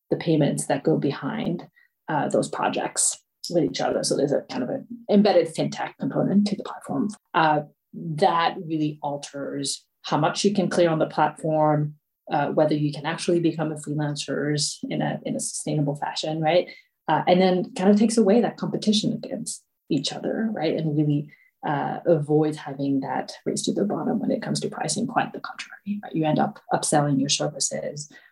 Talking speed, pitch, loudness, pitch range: 185 wpm, 160 Hz, -24 LUFS, 150-205 Hz